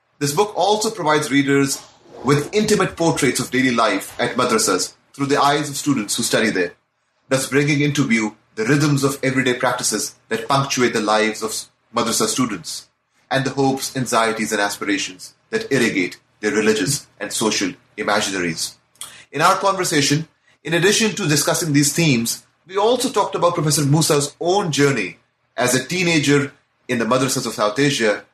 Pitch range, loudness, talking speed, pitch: 125-155 Hz, -19 LUFS, 160 wpm, 140 Hz